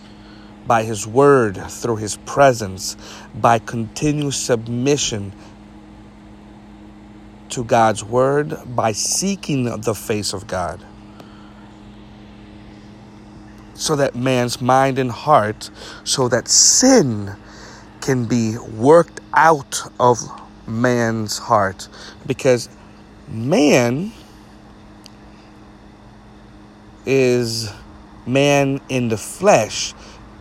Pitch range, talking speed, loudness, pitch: 105-120 Hz, 80 wpm, -17 LUFS, 105 Hz